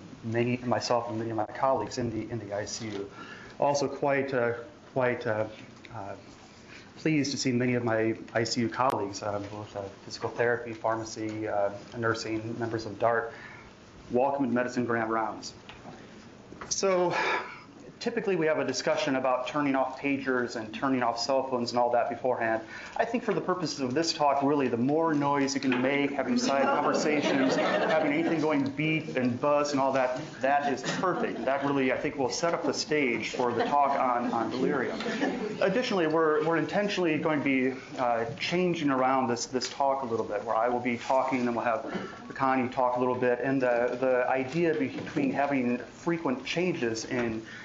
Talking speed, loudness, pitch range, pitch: 185 wpm, -28 LUFS, 115-145 Hz, 125 Hz